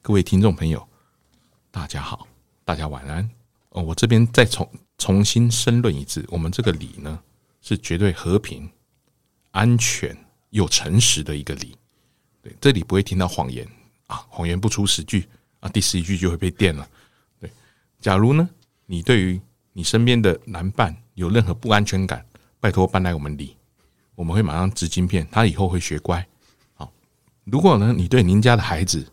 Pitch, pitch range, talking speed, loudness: 95 Hz, 85-115 Hz, 255 characters per minute, -20 LUFS